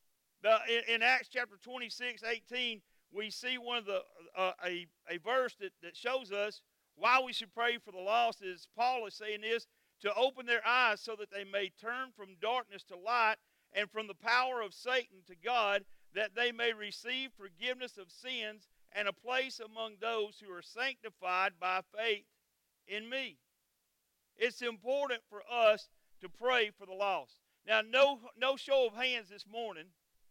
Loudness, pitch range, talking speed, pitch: -35 LUFS, 200-245 Hz, 175 wpm, 225 Hz